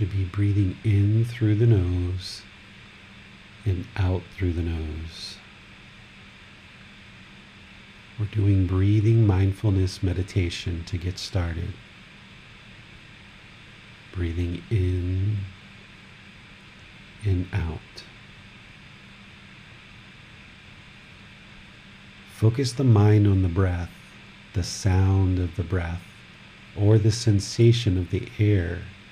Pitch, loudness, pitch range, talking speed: 100 Hz, -24 LUFS, 95-105 Hz, 85 wpm